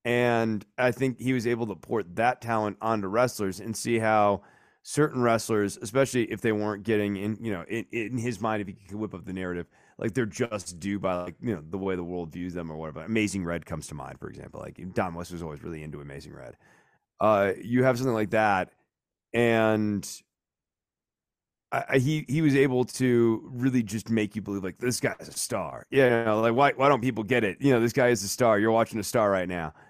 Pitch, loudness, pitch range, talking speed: 110 Hz, -27 LUFS, 95-120 Hz, 235 wpm